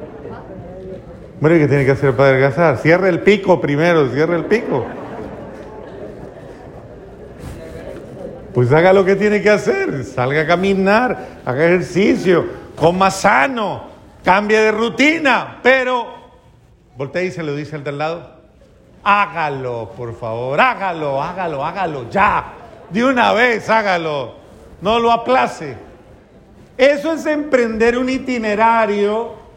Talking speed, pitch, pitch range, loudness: 120 wpm, 190 Hz, 155-225 Hz, -15 LUFS